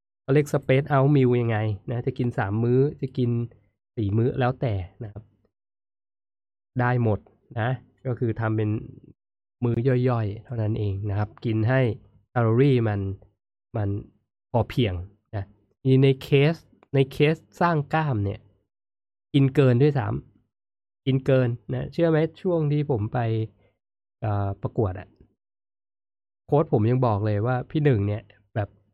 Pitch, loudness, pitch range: 115 Hz, -24 LUFS, 100-130 Hz